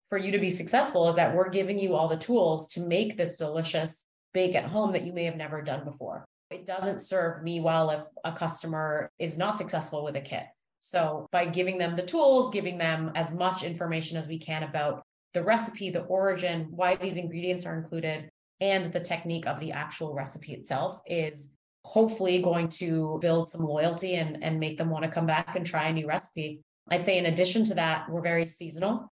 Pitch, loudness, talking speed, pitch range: 170 Hz, -29 LUFS, 210 wpm, 160-185 Hz